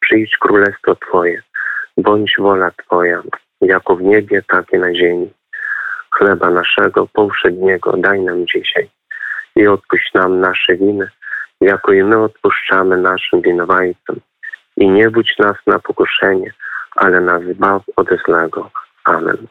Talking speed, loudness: 130 wpm, -13 LUFS